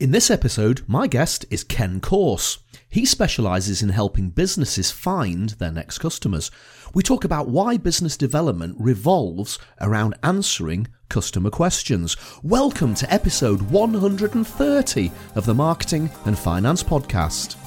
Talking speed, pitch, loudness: 130 wpm, 130 Hz, -21 LUFS